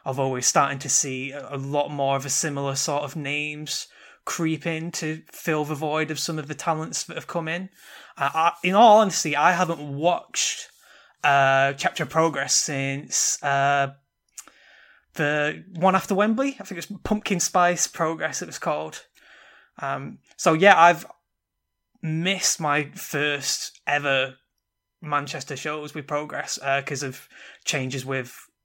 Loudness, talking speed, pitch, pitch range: -23 LUFS, 155 wpm, 150 Hz, 140-170 Hz